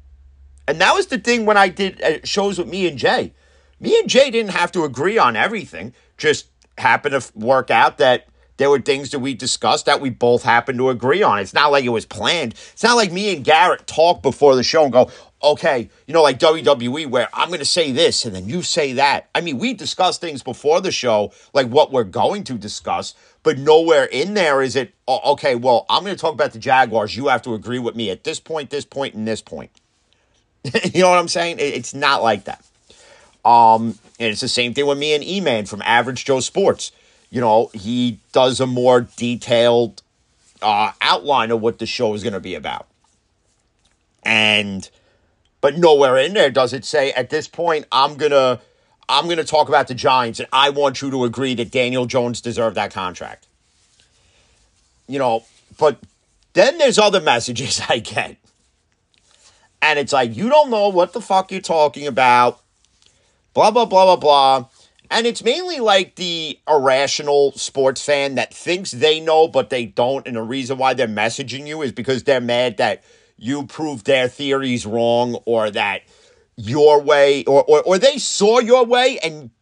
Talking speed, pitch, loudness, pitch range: 195 wpm, 135 Hz, -17 LUFS, 120-160 Hz